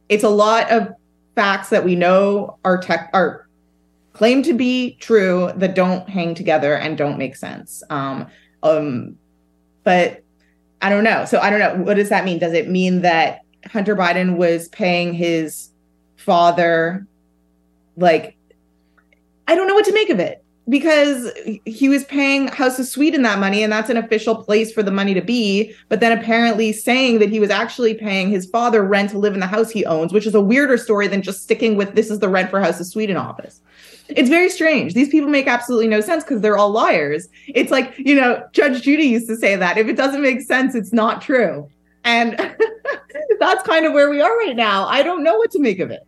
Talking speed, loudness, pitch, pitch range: 210 wpm, -17 LUFS, 210 Hz, 175-250 Hz